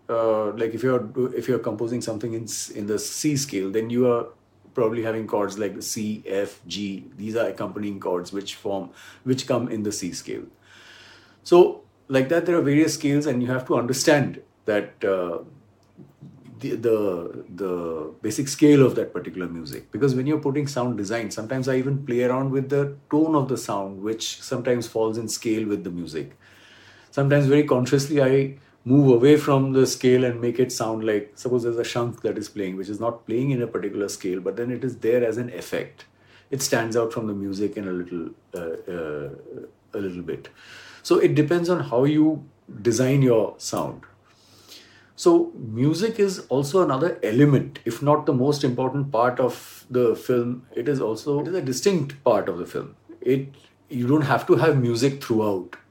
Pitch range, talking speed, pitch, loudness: 110-140 Hz, 195 wpm, 125 Hz, -23 LUFS